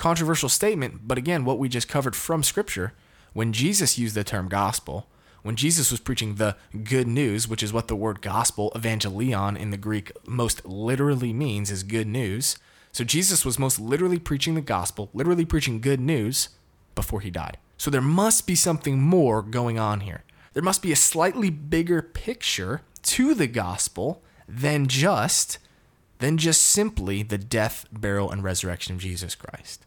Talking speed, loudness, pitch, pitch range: 175 wpm, -24 LUFS, 120 Hz, 105-150 Hz